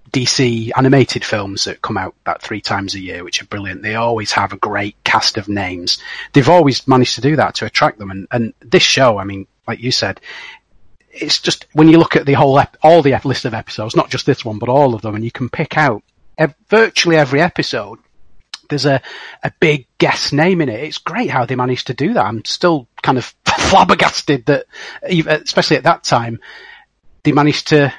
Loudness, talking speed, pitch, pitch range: -14 LUFS, 215 wpm, 130 Hz, 110-150 Hz